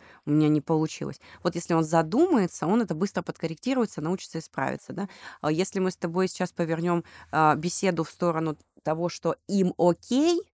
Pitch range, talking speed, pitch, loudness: 160-190 Hz, 160 wpm, 175 Hz, -27 LUFS